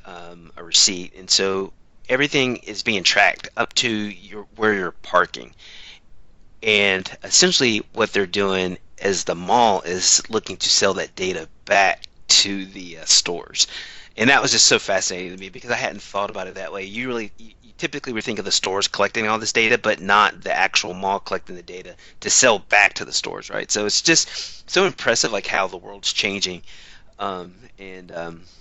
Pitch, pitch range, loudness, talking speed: 100 Hz, 90-110 Hz, -19 LUFS, 190 wpm